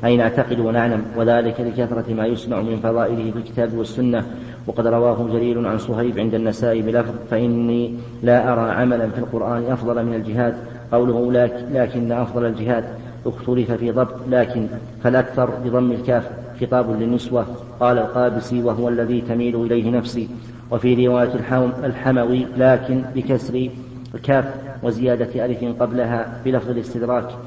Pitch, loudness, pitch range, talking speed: 120 Hz, -20 LUFS, 115-125 Hz, 135 wpm